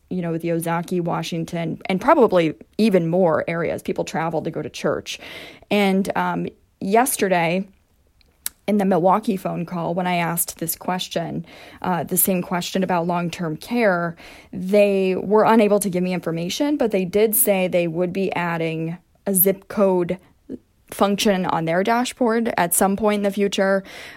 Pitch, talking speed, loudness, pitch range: 185 Hz, 165 wpm, -20 LUFS, 175-200 Hz